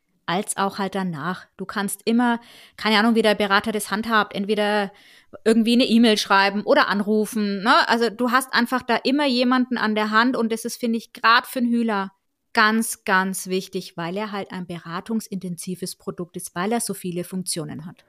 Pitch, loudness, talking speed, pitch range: 210 Hz, -21 LUFS, 190 wpm, 195-230 Hz